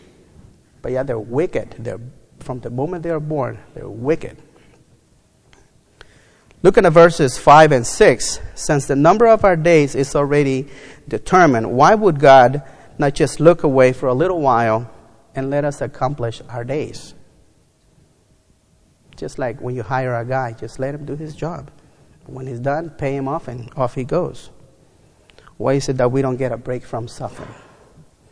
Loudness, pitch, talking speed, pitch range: -16 LUFS, 135 Hz, 170 wpm, 125-150 Hz